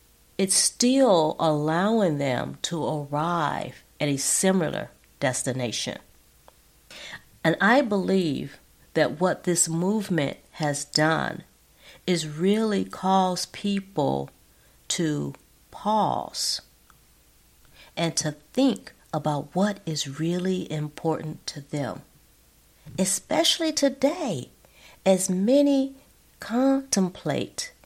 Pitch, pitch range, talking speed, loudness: 175 Hz, 150-200 Hz, 85 wpm, -25 LUFS